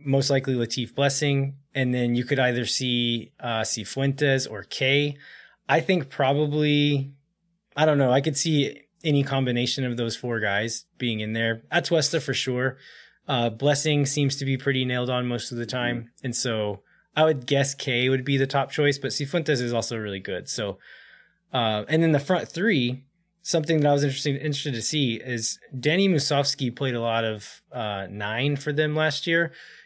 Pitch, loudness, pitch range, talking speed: 135 Hz, -24 LUFS, 120-145 Hz, 185 wpm